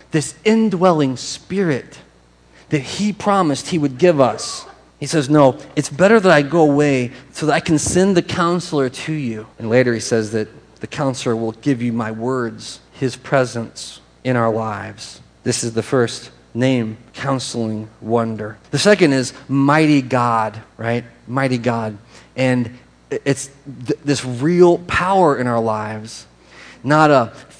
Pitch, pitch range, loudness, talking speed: 130 Hz, 115-150 Hz, -17 LUFS, 155 wpm